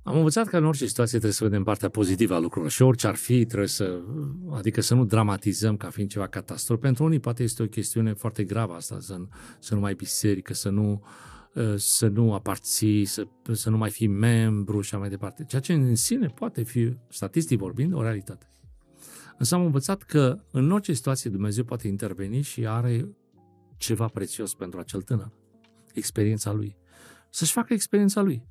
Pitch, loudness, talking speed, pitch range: 115 Hz, -26 LUFS, 190 wpm, 100-125 Hz